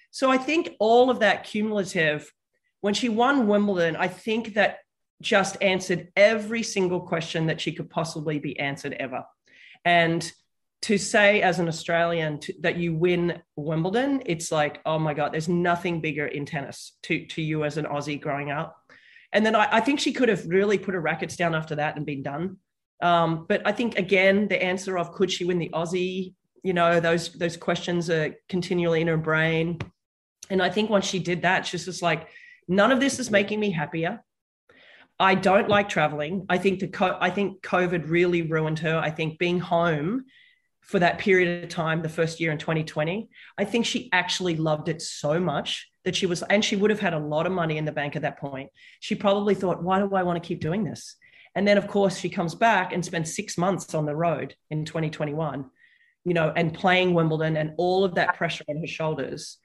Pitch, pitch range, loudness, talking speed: 175 Hz, 160-200 Hz, -24 LUFS, 205 wpm